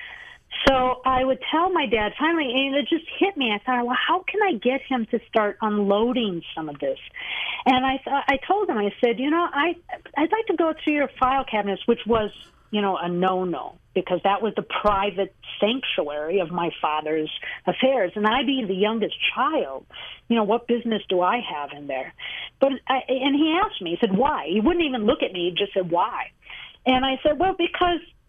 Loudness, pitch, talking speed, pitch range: -23 LUFS, 250 Hz, 210 wpm, 200-285 Hz